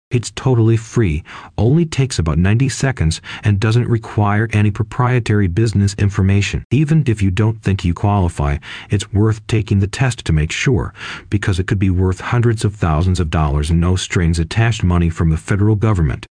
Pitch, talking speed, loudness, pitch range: 105 Hz, 180 wpm, -16 LUFS, 90-115 Hz